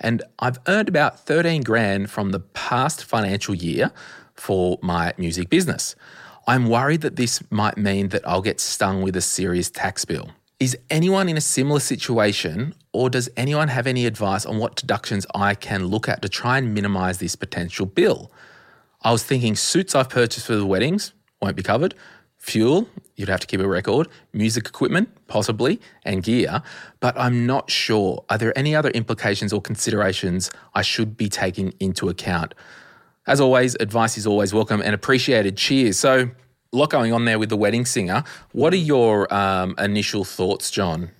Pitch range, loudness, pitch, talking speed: 100-125 Hz, -21 LUFS, 110 Hz, 180 wpm